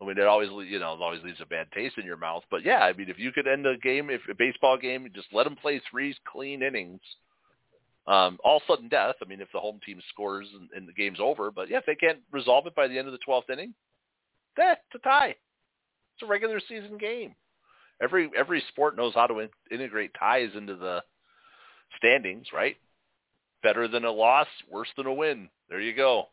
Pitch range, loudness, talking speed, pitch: 100-145 Hz, -27 LUFS, 225 wpm, 125 Hz